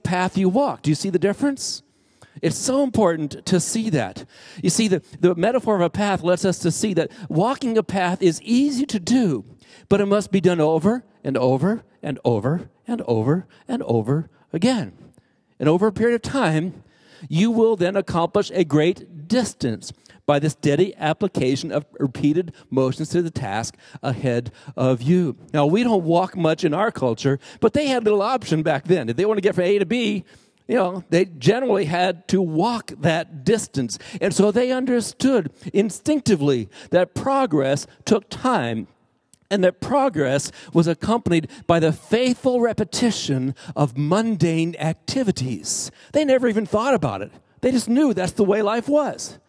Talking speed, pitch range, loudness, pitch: 175 wpm, 155-220 Hz, -21 LUFS, 180 Hz